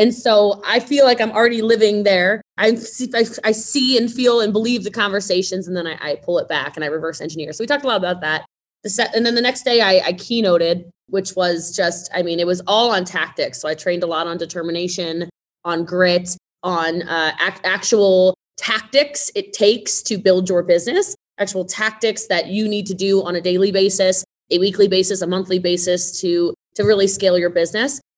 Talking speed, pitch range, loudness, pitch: 200 wpm, 175-220 Hz, -18 LUFS, 190 Hz